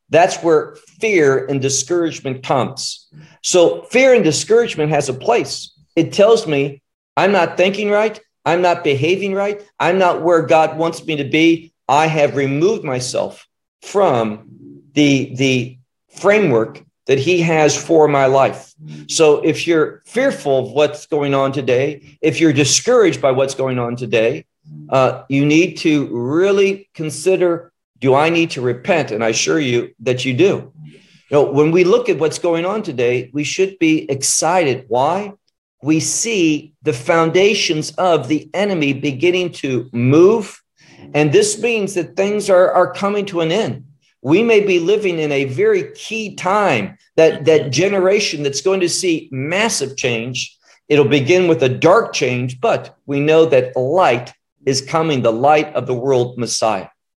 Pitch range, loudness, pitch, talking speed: 135-185 Hz, -16 LUFS, 155 Hz, 160 wpm